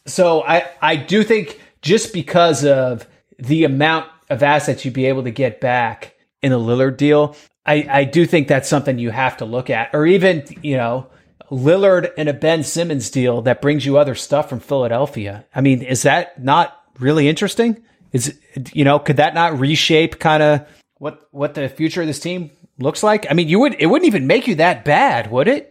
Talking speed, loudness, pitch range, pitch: 205 wpm, -16 LUFS, 135-170 Hz, 150 Hz